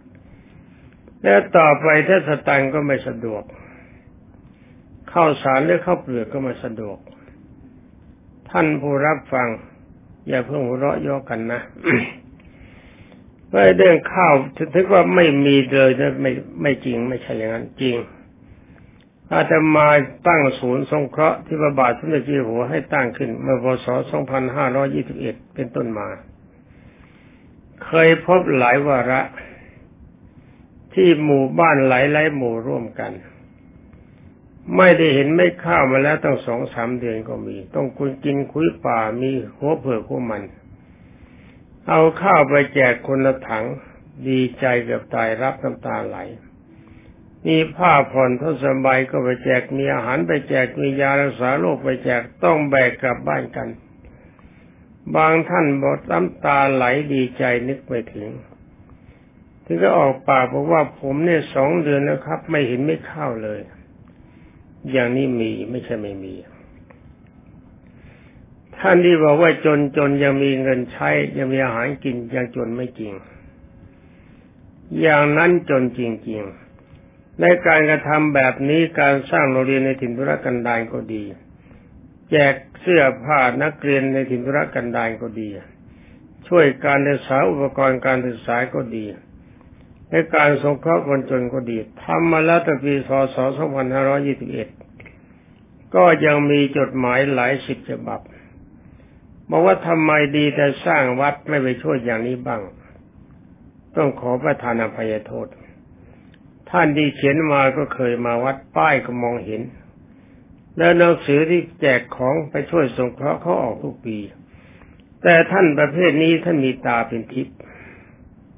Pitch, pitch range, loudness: 135 Hz, 125-150 Hz, -18 LUFS